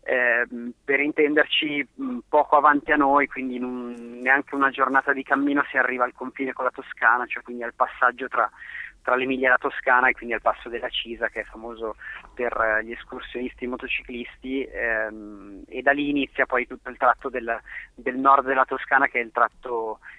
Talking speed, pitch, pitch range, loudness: 195 wpm, 130 Hz, 120-140 Hz, -23 LUFS